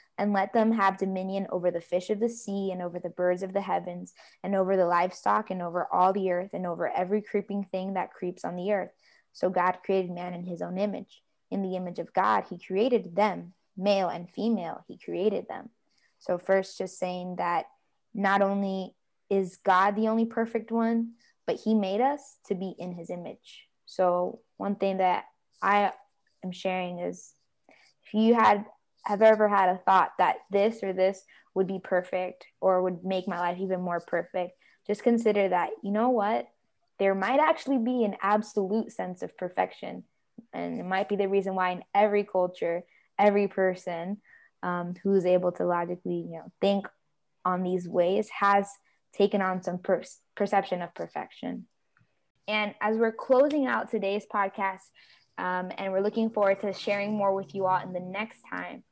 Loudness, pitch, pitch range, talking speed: -28 LUFS, 195 Hz, 180-205 Hz, 185 wpm